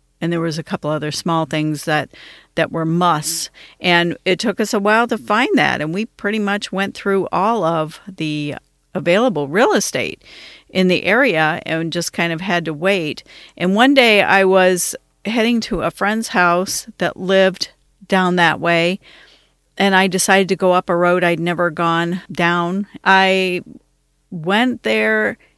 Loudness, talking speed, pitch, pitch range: -17 LUFS, 170 wpm, 180 Hz, 165-195 Hz